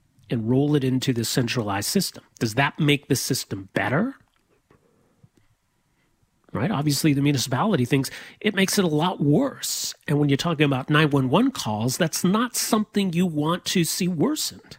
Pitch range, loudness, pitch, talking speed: 130-180 Hz, -23 LUFS, 145 Hz, 160 wpm